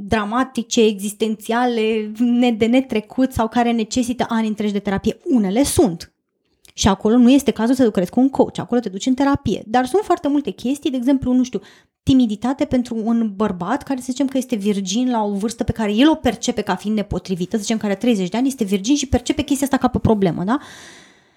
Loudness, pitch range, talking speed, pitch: -19 LUFS, 215-260 Hz, 210 wpm, 235 Hz